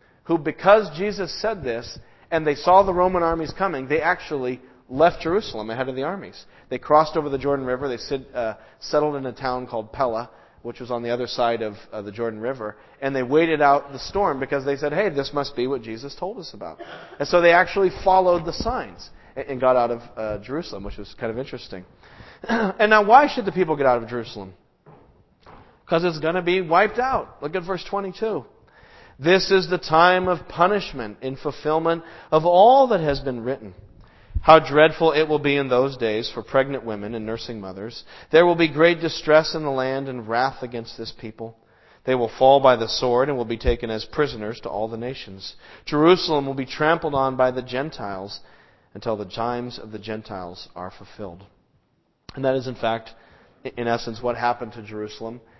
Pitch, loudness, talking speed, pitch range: 135 Hz, -21 LUFS, 205 wpm, 115-165 Hz